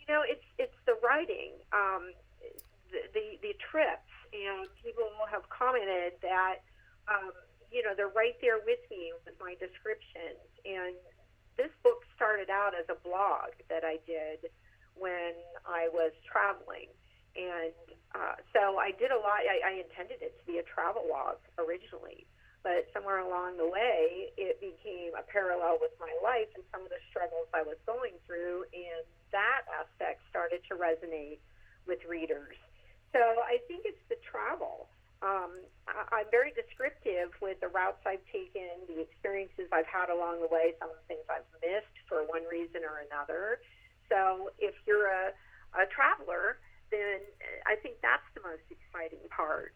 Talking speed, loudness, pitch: 165 wpm, -34 LUFS, 195 Hz